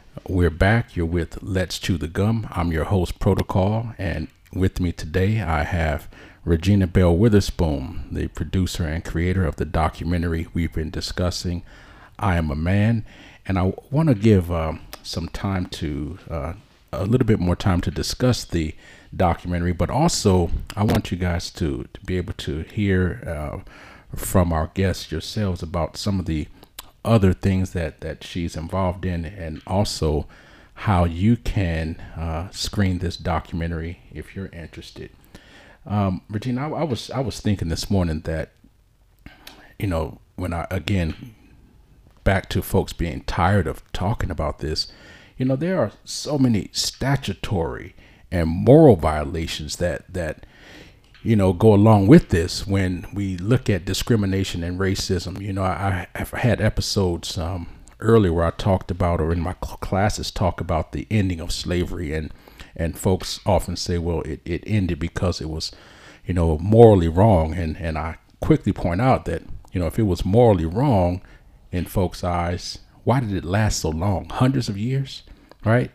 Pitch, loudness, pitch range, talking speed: 95 Hz, -22 LUFS, 85-100 Hz, 165 wpm